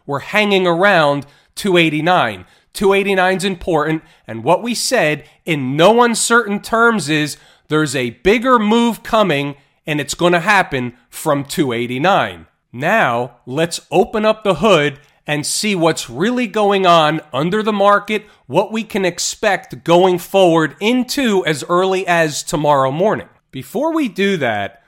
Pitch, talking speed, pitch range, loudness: 175 Hz, 140 wpm, 150-205 Hz, -15 LUFS